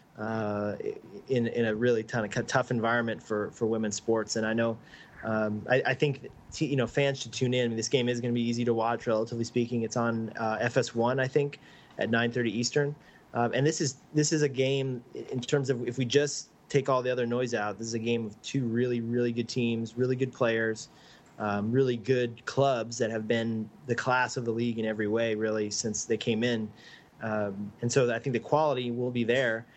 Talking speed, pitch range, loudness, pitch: 225 wpm, 115-125 Hz, -29 LUFS, 120 Hz